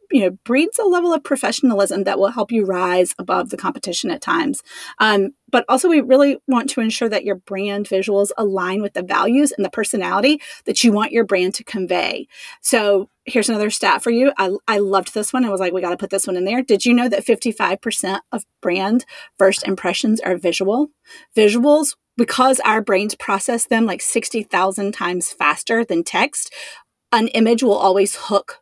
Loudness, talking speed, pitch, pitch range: -18 LUFS, 195 wpm, 215 Hz, 195-245 Hz